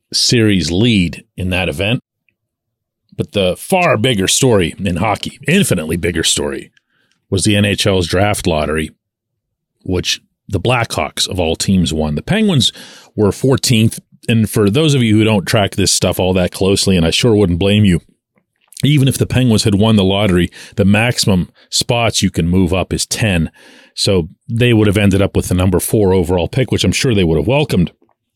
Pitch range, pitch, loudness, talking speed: 90-115 Hz, 105 Hz, -14 LUFS, 180 wpm